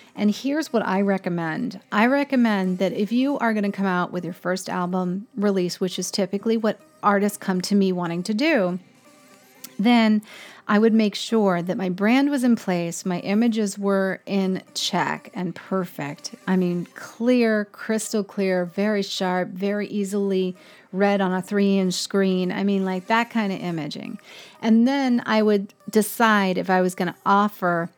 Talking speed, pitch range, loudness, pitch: 175 wpm, 185-220 Hz, -22 LUFS, 200 Hz